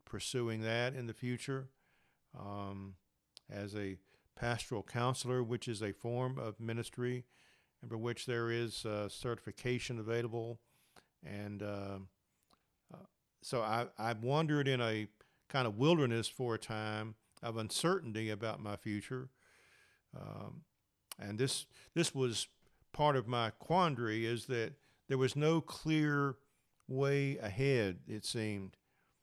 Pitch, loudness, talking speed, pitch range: 120 Hz, -38 LUFS, 130 wpm, 105-130 Hz